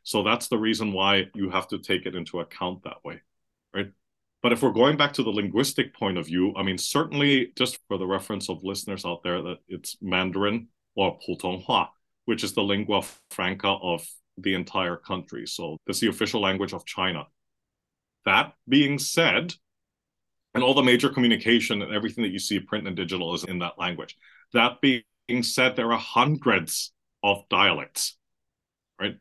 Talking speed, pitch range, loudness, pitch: 180 wpm, 95-120 Hz, -25 LUFS, 100 Hz